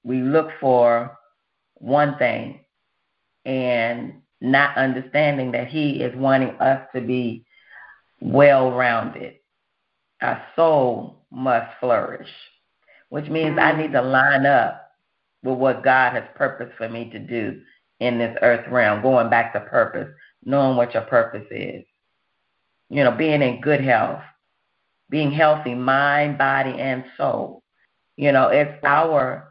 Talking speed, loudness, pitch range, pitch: 135 wpm, -20 LUFS, 120-145 Hz, 130 Hz